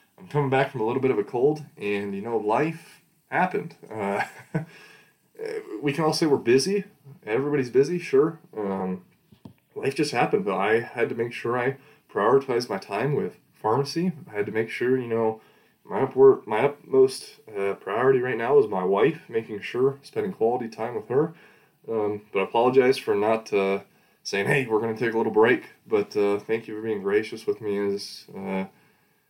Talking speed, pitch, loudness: 190 wpm, 145 Hz, -25 LUFS